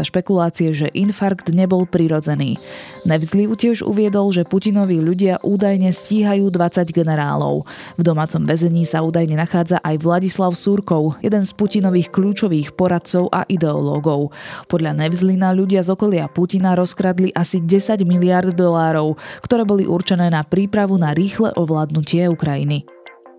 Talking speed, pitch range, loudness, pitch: 130 wpm, 160-195 Hz, -17 LUFS, 180 Hz